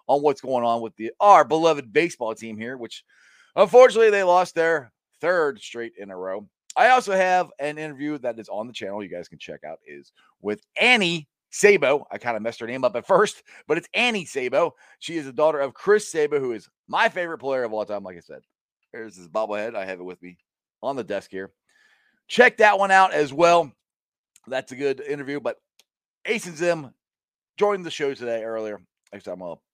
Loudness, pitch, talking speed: -21 LUFS, 155 Hz, 210 wpm